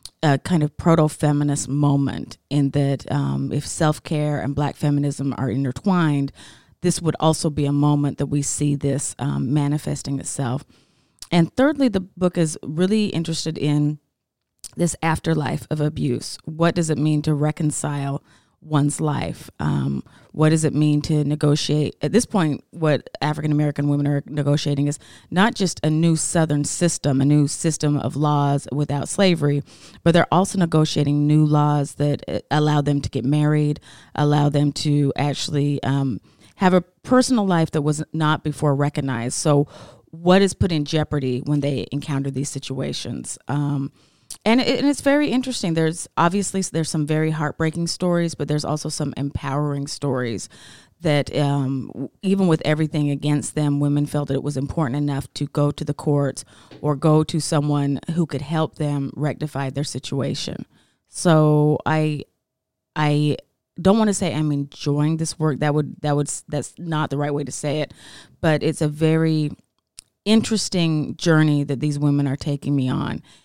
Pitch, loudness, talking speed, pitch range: 150 Hz, -21 LUFS, 165 wpm, 140-160 Hz